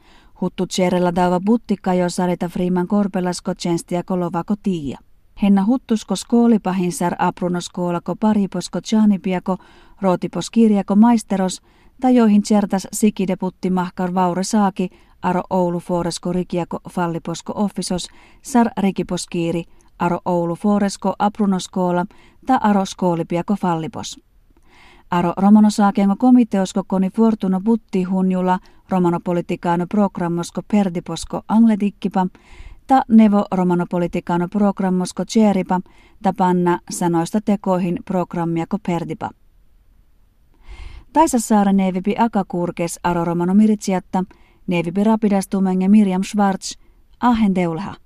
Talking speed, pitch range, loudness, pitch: 95 wpm, 180-205 Hz, -19 LUFS, 185 Hz